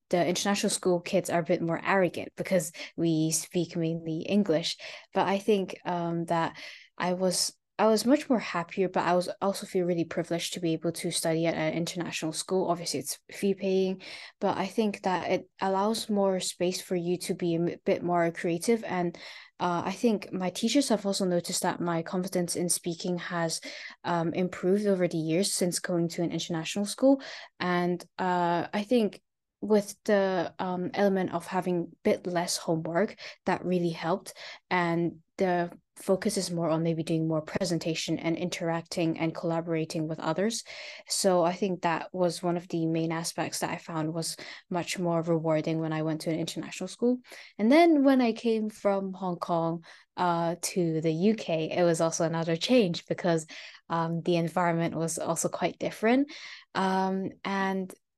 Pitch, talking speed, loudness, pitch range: 175 Hz, 175 wpm, -29 LUFS, 165-195 Hz